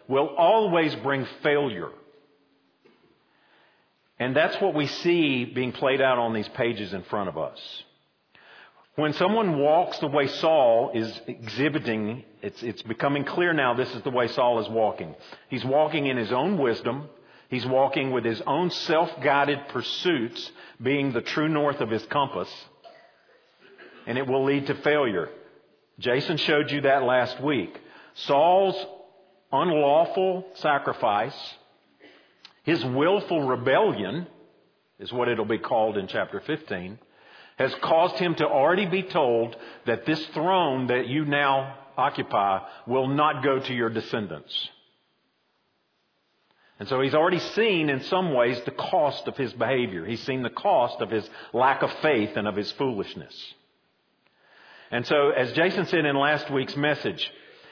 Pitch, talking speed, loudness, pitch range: 140 Hz, 145 wpm, -25 LUFS, 125-155 Hz